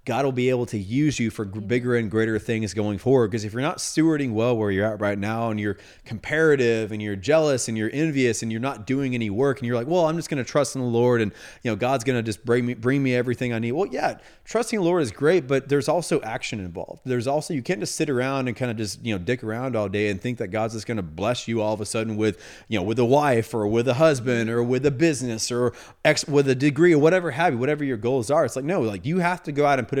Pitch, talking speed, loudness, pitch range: 125 Hz, 290 wpm, -23 LUFS, 110-140 Hz